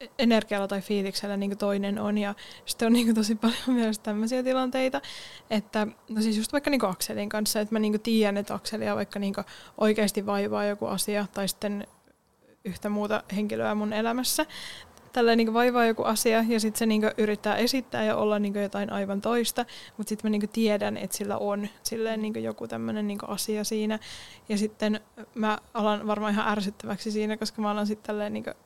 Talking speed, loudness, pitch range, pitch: 155 wpm, -27 LUFS, 205-225 Hz, 215 Hz